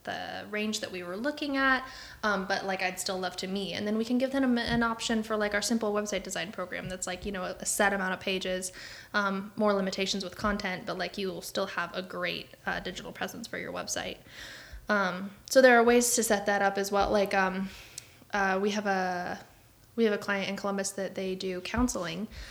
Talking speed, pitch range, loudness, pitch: 225 wpm, 185-215 Hz, -30 LUFS, 200 Hz